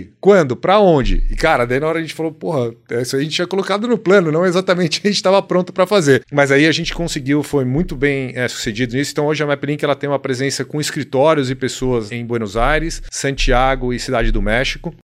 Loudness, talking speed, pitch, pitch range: -16 LUFS, 235 wpm, 145 Hz, 130-165 Hz